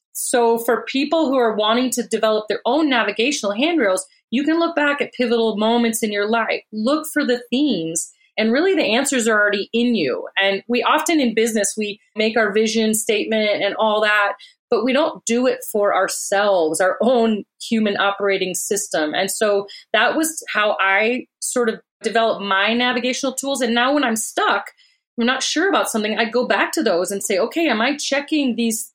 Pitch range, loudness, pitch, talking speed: 210-275 Hz, -19 LUFS, 230 Hz, 195 wpm